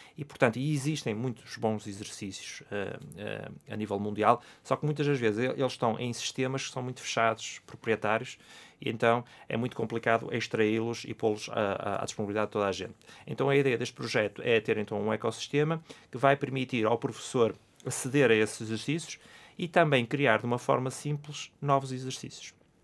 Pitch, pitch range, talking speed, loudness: 120 Hz, 110-140 Hz, 175 wpm, -30 LUFS